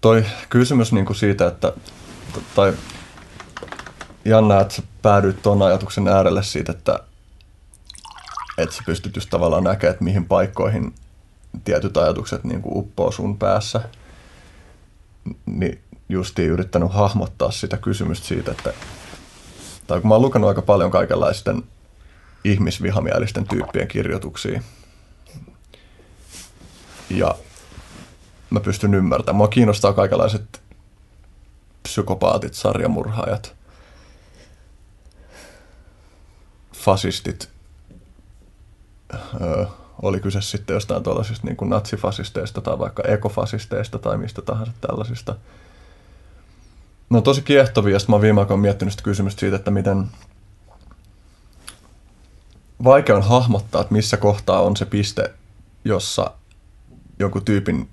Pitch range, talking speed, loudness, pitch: 90-110 Hz, 105 wpm, -19 LUFS, 100 Hz